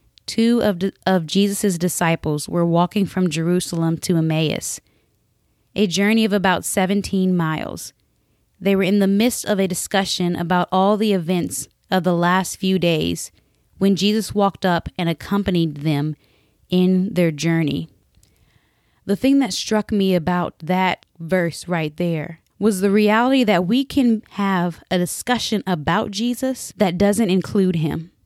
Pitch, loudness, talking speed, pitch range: 185 Hz, -19 LUFS, 145 wpm, 170-205 Hz